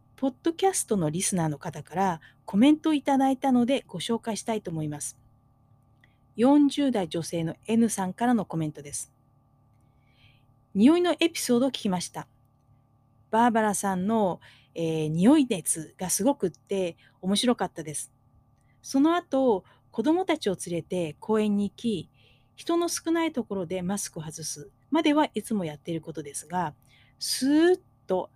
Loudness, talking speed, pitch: -26 LUFS, 305 characters per minute, 185 Hz